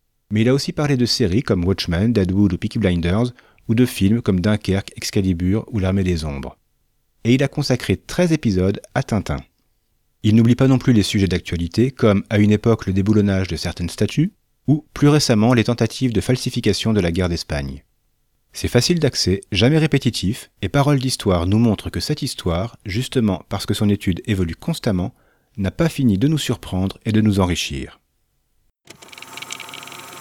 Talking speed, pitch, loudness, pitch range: 175 wpm, 105 Hz, -19 LUFS, 95-125 Hz